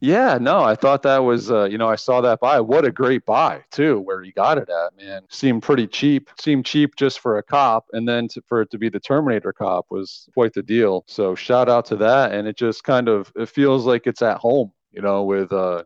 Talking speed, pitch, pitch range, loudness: 255 wpm, 120 Hz, 105-135 Hz, -19 LUFS